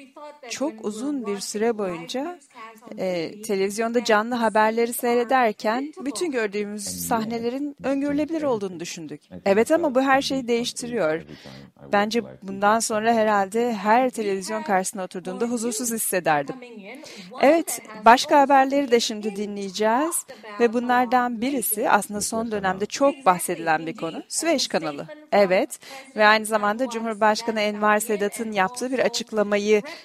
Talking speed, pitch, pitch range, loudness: 120 wpm, 225 Hz, 205-255 Hz, -22 LUFS